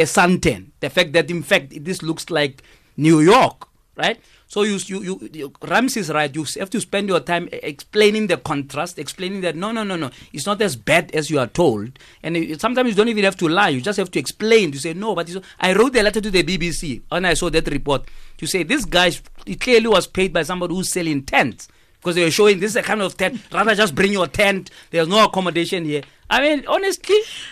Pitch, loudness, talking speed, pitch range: 180 Hz, -19 LUFS, 235 wpm, 160-205 Hz